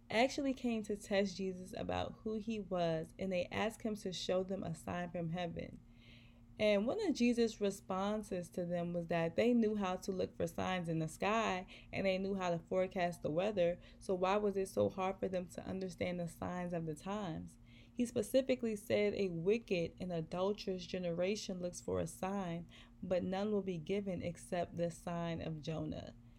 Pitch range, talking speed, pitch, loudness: 170-205 Hz, 190 wpm, 185 Hz, -39 LUFS